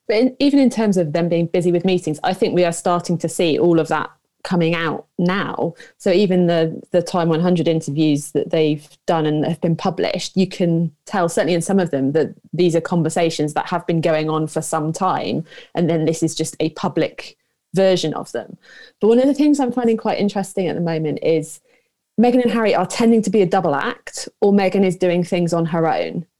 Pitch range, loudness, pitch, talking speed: 160-195 Hz, -18 LUFS, 175 Hz, 225 wpm